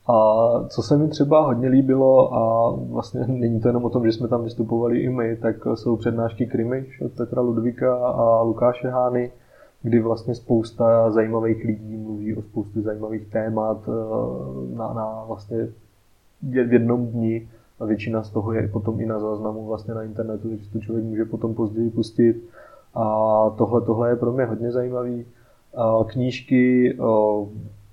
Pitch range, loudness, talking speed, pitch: 110-120 Hz, -22 LUFS, 160 wpm, 115 Hz